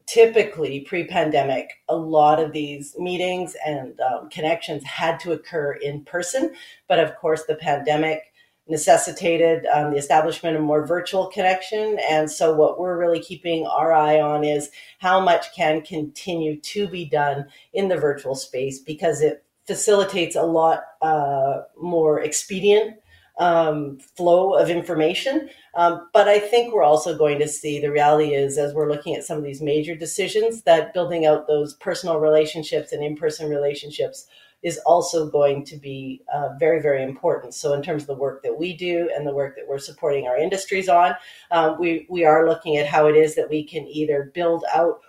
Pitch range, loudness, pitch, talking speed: 150-175 Hz, -21 LUFS, 160 Hz, 180 wpm